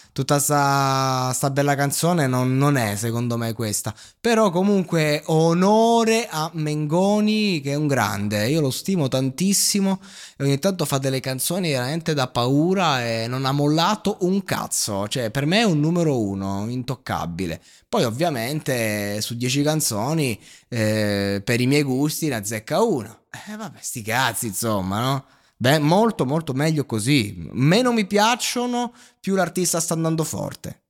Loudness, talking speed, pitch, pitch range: -21 LUFS, 155 wpm, 145 Hz, 120-175 Hz